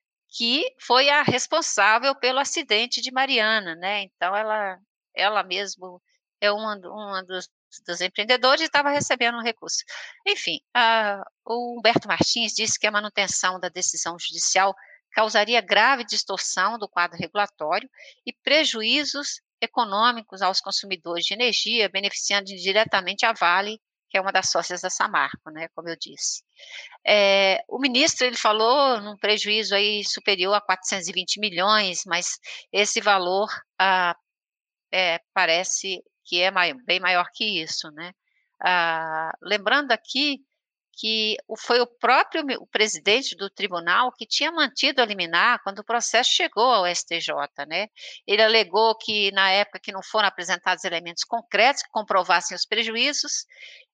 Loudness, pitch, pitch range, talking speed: -22 LUFS, 210 Hz, 185-245 Hz, 140 wpm